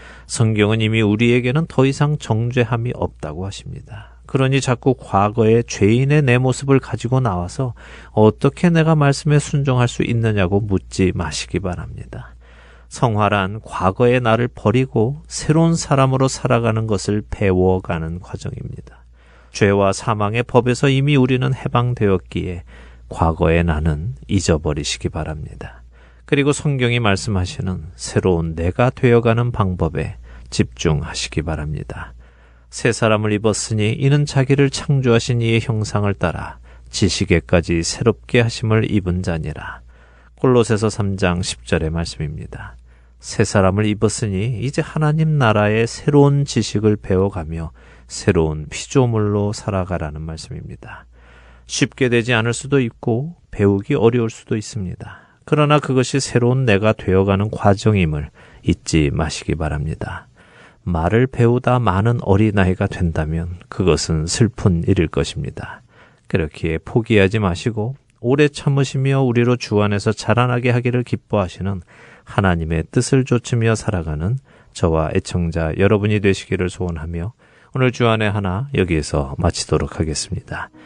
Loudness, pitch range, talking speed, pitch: -18 LUFS, 90-125 Hz, 315 characters per minute, 105 Hz